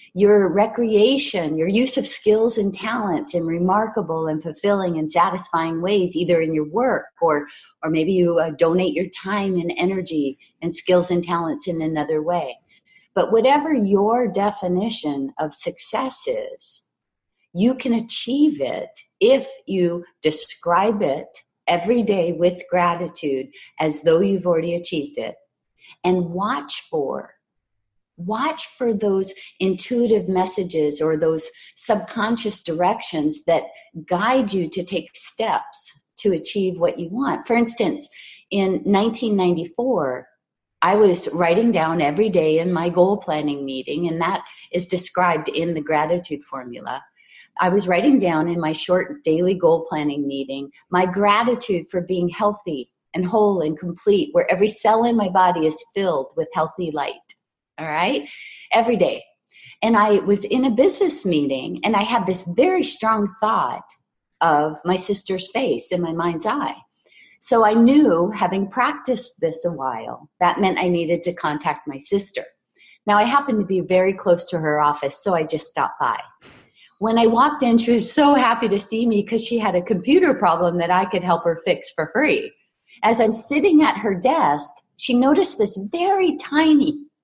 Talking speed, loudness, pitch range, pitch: 160 wpm, -20 LUFS, 170-230 Hz, 185 Hz